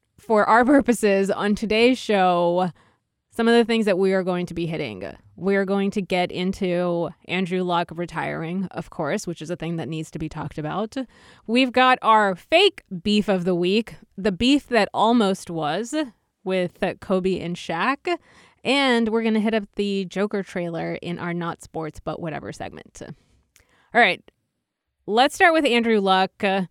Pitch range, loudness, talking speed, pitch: 175-225 Hz, -22 LUFS, 175 wpm, 195 Hz